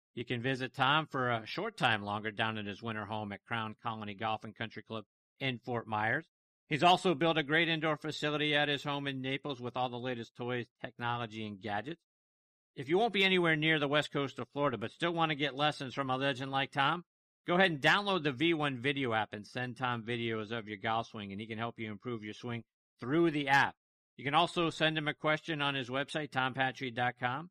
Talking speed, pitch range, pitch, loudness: 225 wpm, 115-150 Hz, 130 Hz, -33 LUFS